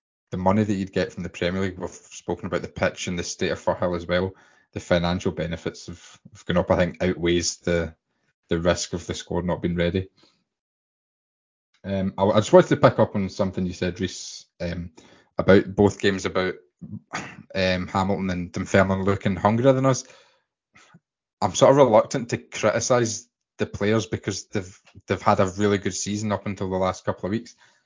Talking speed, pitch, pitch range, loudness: 185 wpm, 95 Hz, 90-105 Hz, -23 LUFS